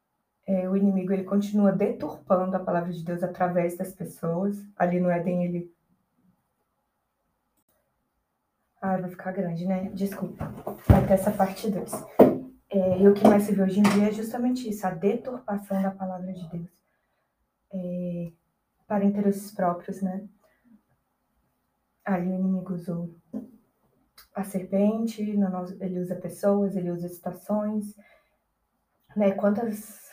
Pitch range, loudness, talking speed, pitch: 180-205 Hz, -26 LUFS, 130 wpm, 190 Hz